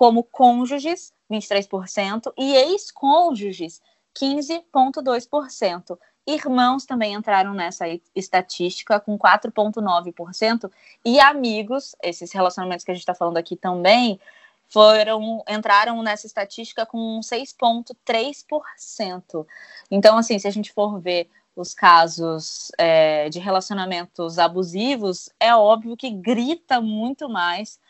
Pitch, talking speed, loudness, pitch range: 215 Hz, 110 wpm, -20 LUFS, 180-245 Hz